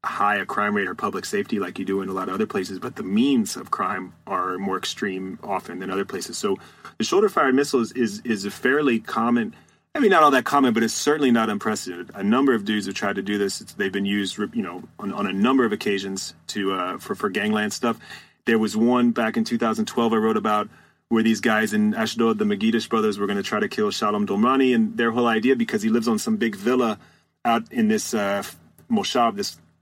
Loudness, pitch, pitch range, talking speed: -23 LUFS, 110 Hz, 100-120 Hz, 235 wpm